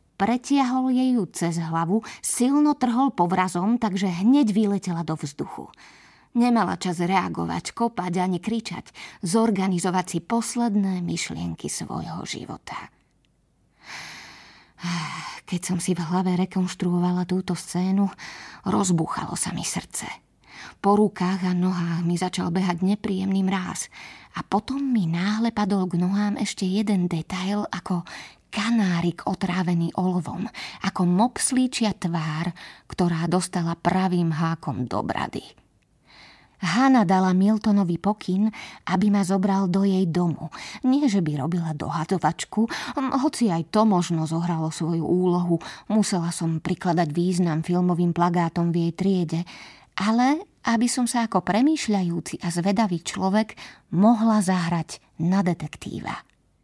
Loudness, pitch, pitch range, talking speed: -24 LUFS, 185 Hz, 175-210 Hz, 120 wpm